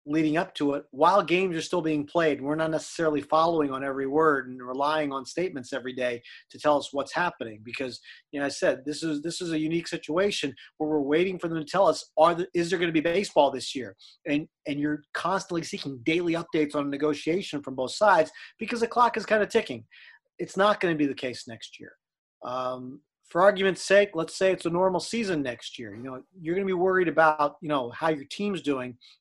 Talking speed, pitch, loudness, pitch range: 230 wpm, 155 Hz, -26 LUFS, 140-180 Hz